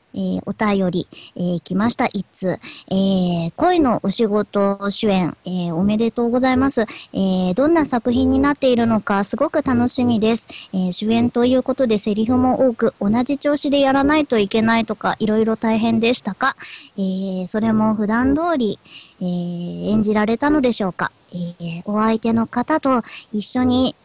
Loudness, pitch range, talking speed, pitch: -19 LUFS, 195-255 Hz, 330 characters per minute, 225 Hz